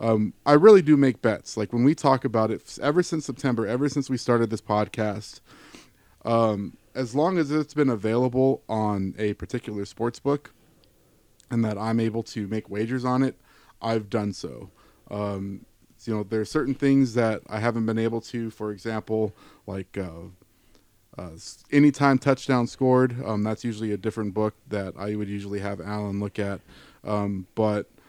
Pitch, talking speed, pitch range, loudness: 110 Hz, 175 wpm, 105-130 Hz, -25 LUFS